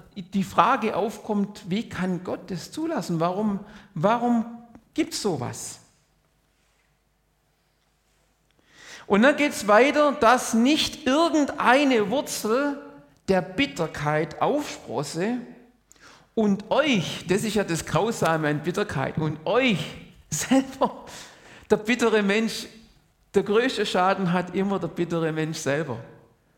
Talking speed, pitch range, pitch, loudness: 110 wpm, 175-245 Hz, 210 Hz, -24 LUFS